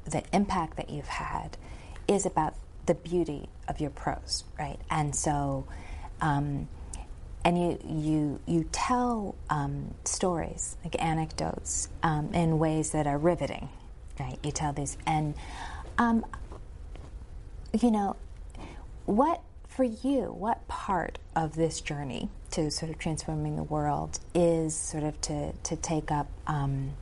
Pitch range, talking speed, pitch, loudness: 145-170 Hz, 135 wpm, 155 Hz, -31 LUFS